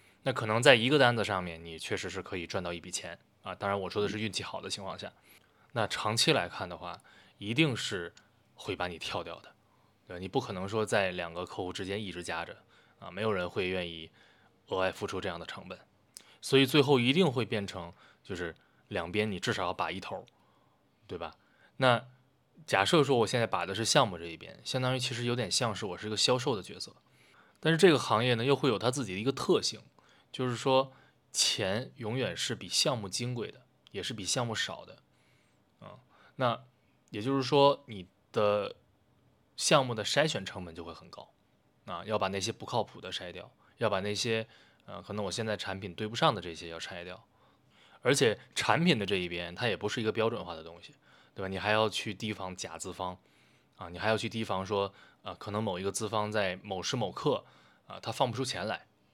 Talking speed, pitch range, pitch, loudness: 295 characters per minute, 95-125 Hz, 105 Hz, -31 LUFS